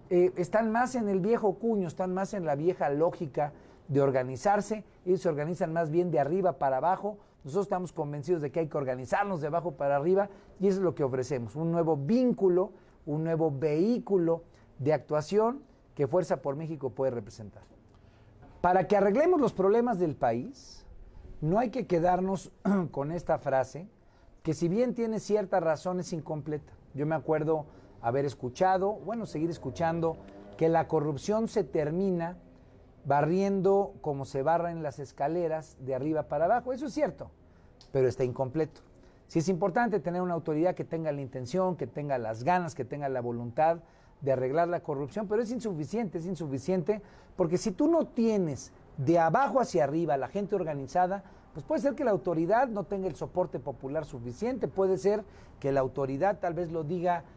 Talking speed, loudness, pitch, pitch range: 175 wpm, -30 LUFS, 170 Hz, 140-195 Hz